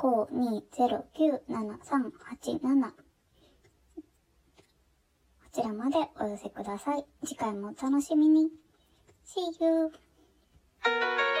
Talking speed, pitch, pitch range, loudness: 135 characters per minute, 275 Hz, 230-315 Hz, -30 LUFS